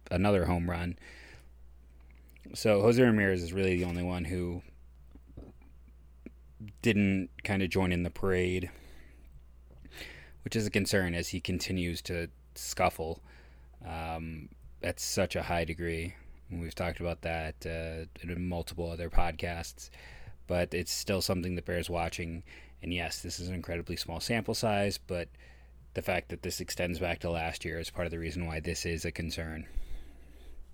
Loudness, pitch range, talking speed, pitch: -33 LUFS, 70-90 Hz, 155 wpm, 85 Hz